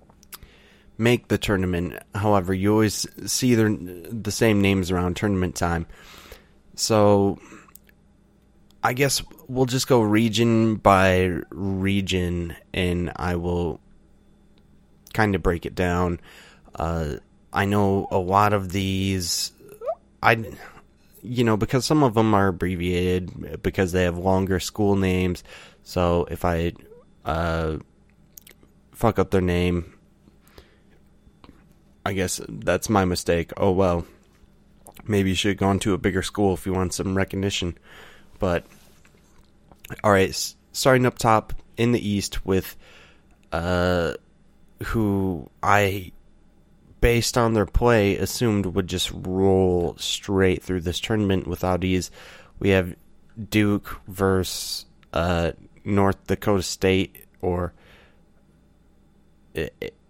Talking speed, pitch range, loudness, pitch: 115 wpm, 90-105 Hz, -23 LUFS, 95 Hz